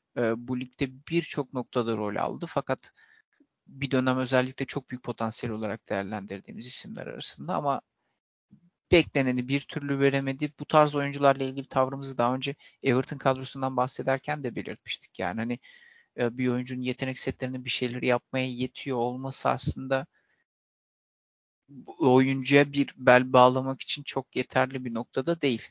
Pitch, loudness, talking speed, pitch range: 130 Hz, -28 LUFS, 130 wpm, 125-140 Hz